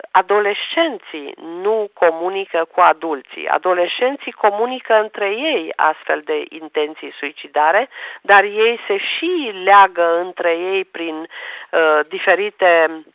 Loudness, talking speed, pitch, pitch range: -17 LUFS, 105 wpm, 195 Hz, 170-220 Hz